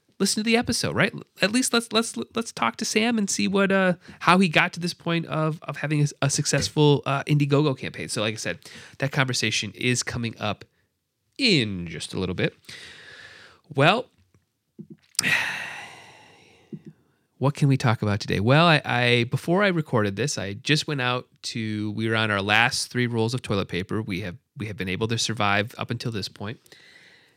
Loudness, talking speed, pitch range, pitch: -23 LUFS, 190 wpm, 110-170 Hz, 135 Hz